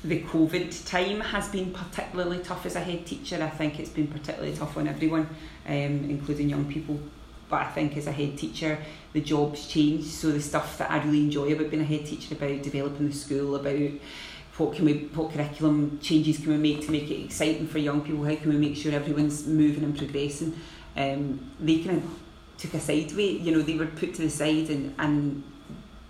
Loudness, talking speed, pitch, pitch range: -28 LUFS, 215 wpm, 150 Hz, 145-160 Hz